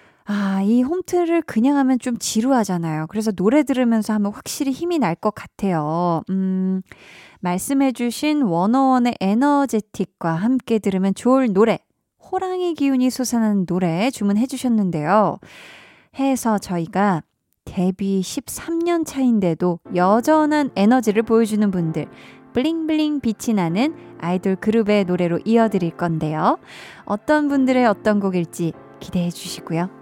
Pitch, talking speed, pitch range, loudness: 215 Hz, 300 characters per minute, 185-260 Hz, -20 LUFS